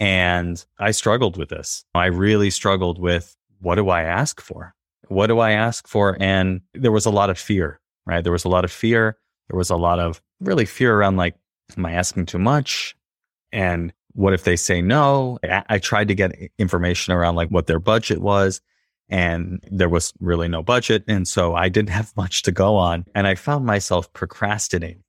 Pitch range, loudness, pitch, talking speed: 90-105 Hz, -20 LUFS, 95 Hz, 200 wpm